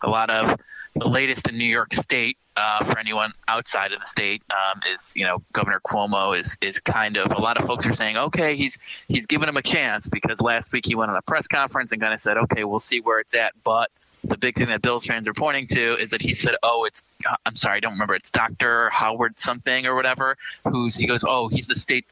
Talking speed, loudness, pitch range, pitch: 250 wpm, -22 LUFS, 110-130 Hz, 120 Hz